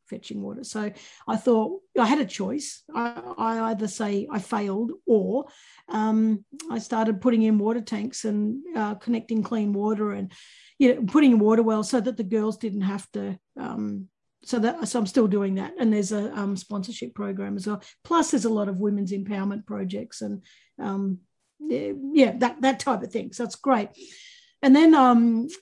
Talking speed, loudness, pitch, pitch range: 185 wpm, -24 LUFS, 225 Hz, 205-255 Hz